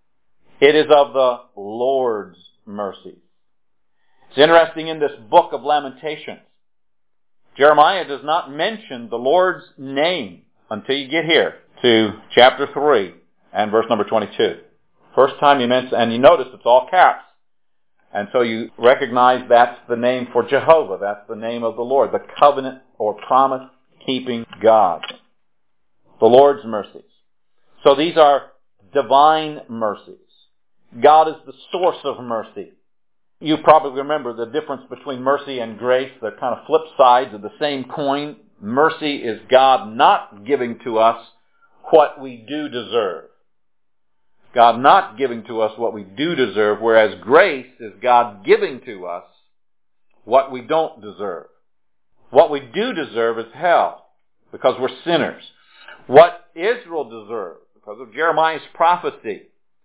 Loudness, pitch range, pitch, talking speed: -17 LUFS, 120-155 Hz, 135 Hz, 140 wpm